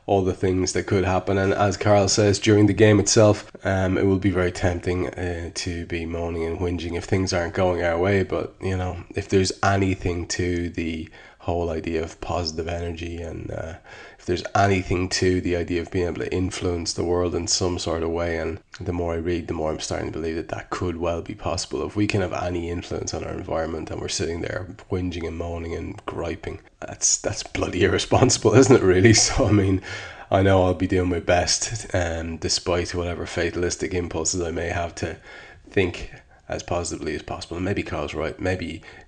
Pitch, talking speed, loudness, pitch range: 90 Hz, 210 wpm, -23 LUFS, 85-95 Hz